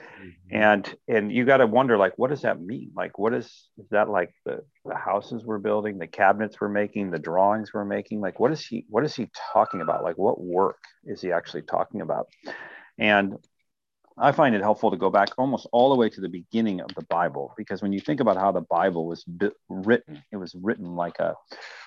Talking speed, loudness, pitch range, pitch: 220 wpm, -25 LUFS, 95-105 Hz, 100 Hz